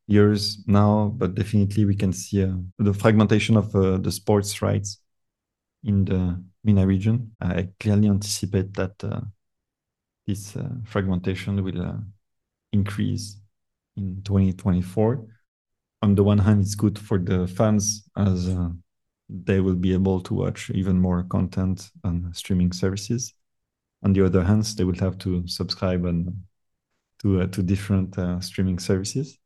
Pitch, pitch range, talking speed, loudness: 100 Hz, 95-105 Hz, 145 wpm, -23 LUFS